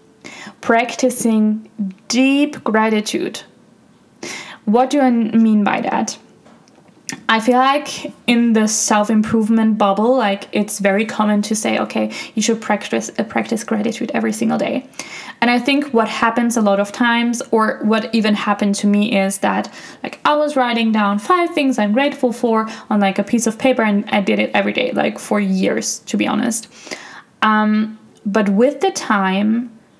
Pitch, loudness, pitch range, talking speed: 225 Hz, -17 LUFS, 210-245 Hz, 165 wpm